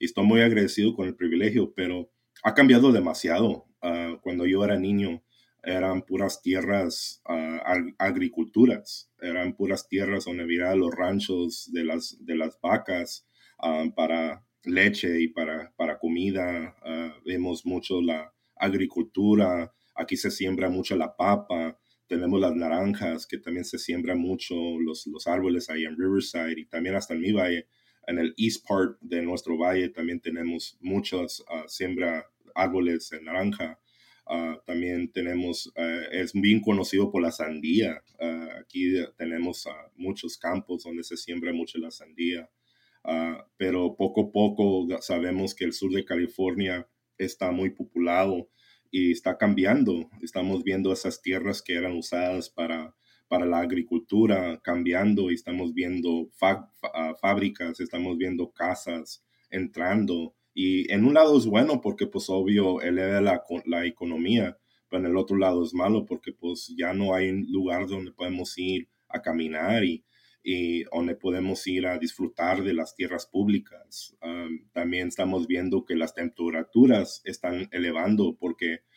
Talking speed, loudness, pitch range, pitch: 150 wpm, -27 LUFS, 85-95 Hz, 90 Hz